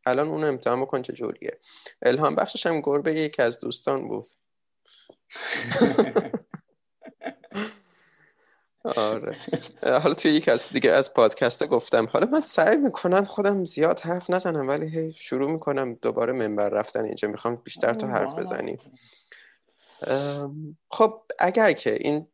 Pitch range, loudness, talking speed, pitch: 145-215 Hz, -24 LUFS, 130 wpm, 170 Hz